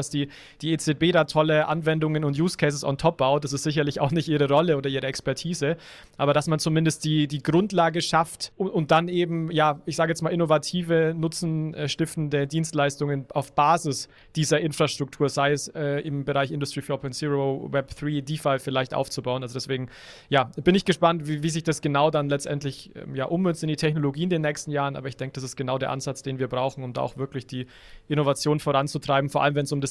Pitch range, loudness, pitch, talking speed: 140-160 Hz, -25 LUFS, 150 Hz, 210 wpm